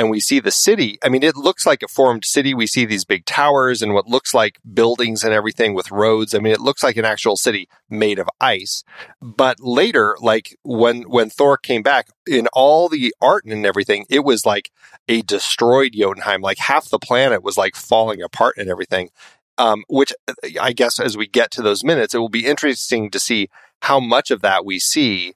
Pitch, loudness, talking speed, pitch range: 120 Hz, -16 LUFS, 215 wpm, 110-140 Hz